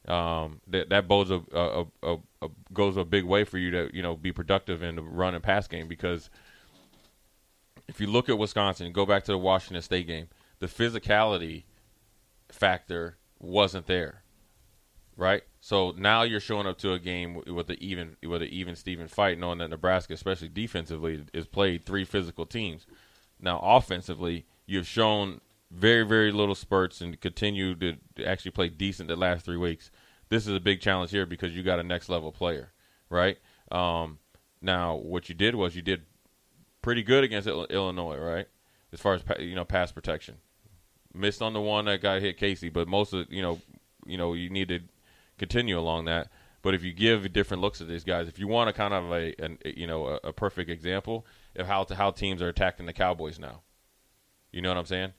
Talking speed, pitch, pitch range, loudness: 200 wpm, 95 Hz, 85-100 Hz, -29 LUFS